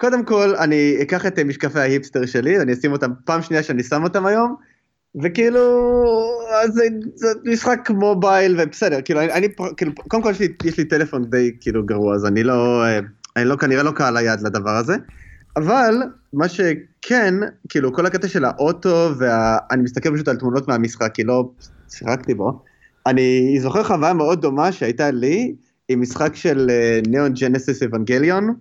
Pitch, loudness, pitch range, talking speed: 150 Hz, -18 LUFS, 125-195 Hz, 165 wpm